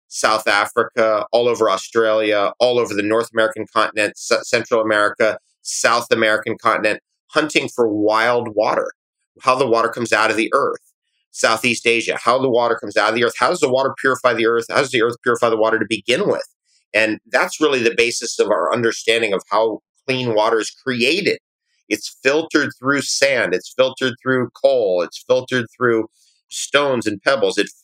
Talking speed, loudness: 185 wpm, -18 LUFS